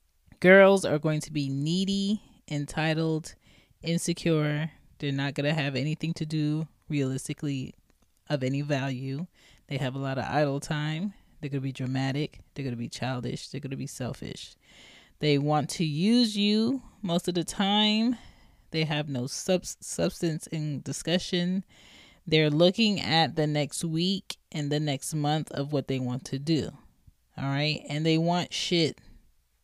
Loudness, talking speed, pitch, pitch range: -28 LUFS, 160 wpm, 150 Hz, 140-170 Hz